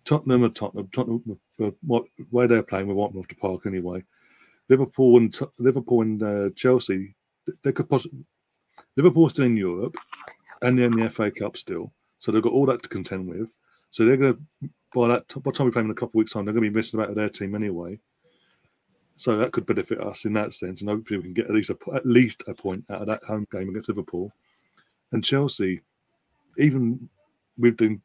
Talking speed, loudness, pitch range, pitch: 220 wpm, -24 LUFS, 105-125 Hz, 110 Hz